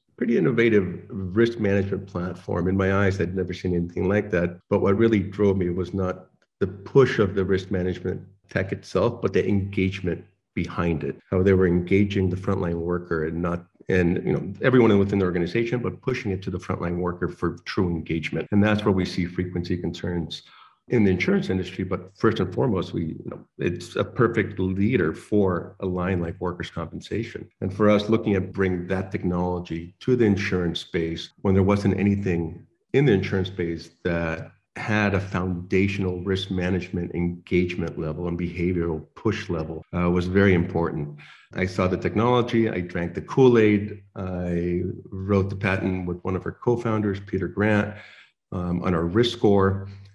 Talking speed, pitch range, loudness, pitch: 175 wpm, 90-100 Hz, -24 LUFS, 95 Hz